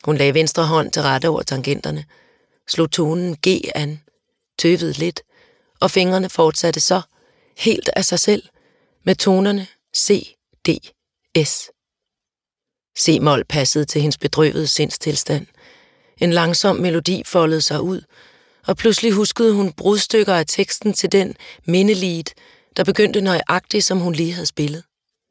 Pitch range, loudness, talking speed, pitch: 155-195 Hz, -18 LUFS, 140 wpm, 175 Hz